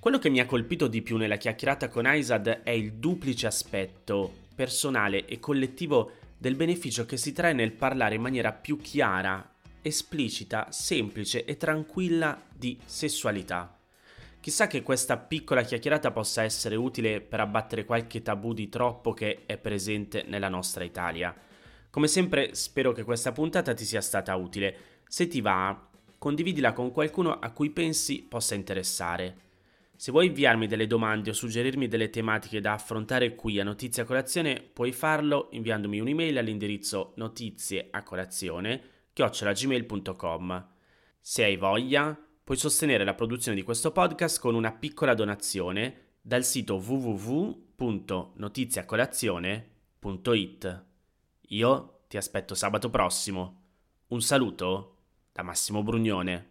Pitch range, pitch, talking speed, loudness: 100-130 Hz, 115 Hz, 135 wpm, -29 LUFS